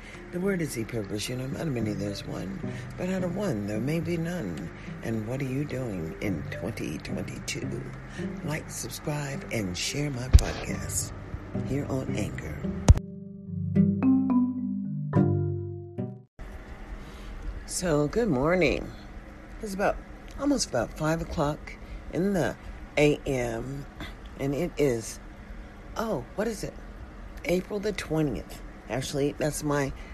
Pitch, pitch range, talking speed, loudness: 140 Hz, 110-175 Hz, 125 wpm, -29 LUFS